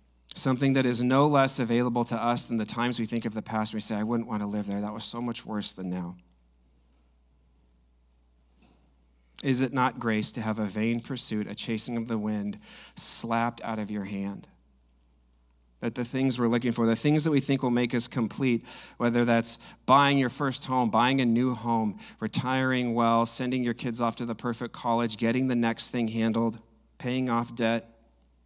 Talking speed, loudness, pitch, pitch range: 195 wpm, -27 LUFS, 115 Hz, 105-120 Hz